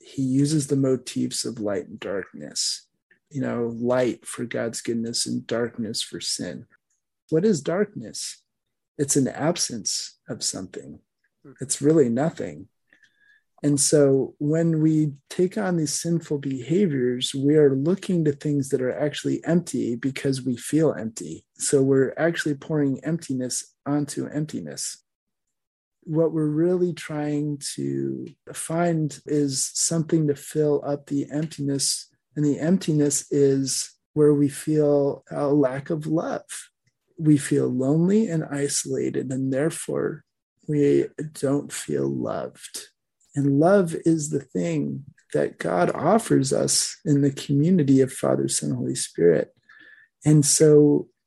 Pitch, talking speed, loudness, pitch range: 145 Hz, 130 wpm, -23 LUFS, 135-155 Hz